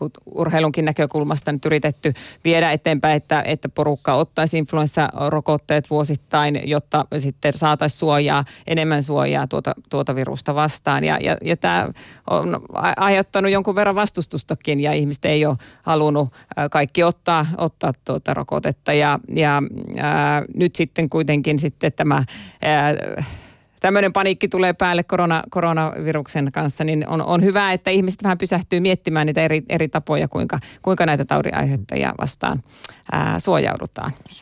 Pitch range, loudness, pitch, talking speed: 150-170 Hz, -20 LUFS, 155 Hz, 135 wpm